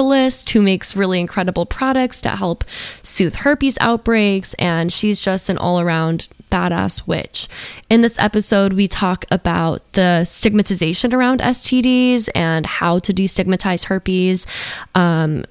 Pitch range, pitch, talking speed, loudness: 175-230 Hz, 195 Hz, 130 wpm, -16 LUFS